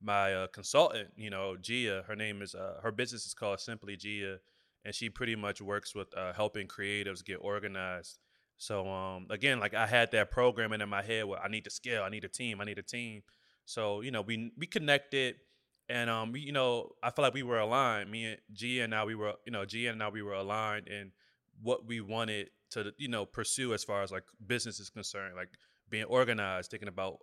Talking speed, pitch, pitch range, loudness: 225 wpm, 105 Hz, 100-115 Hz, -35 LUFS